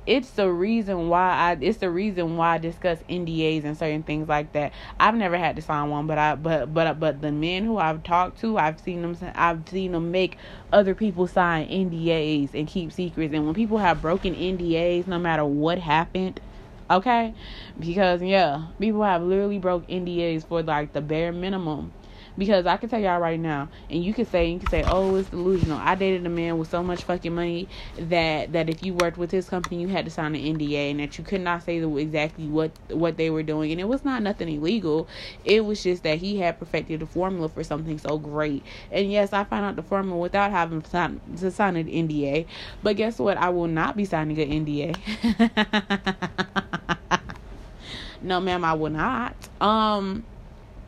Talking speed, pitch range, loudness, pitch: 205 wpm, 155-190 Hz, -25 LUFS, 170 Hz